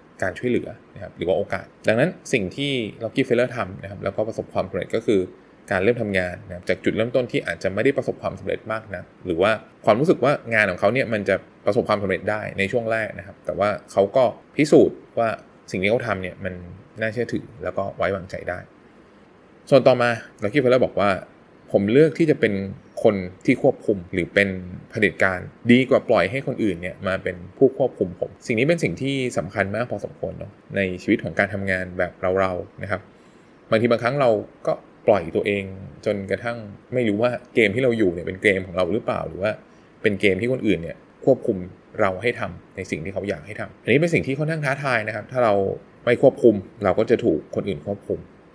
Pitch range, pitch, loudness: 95-120 Hz, 105 Hz, -22 LUFS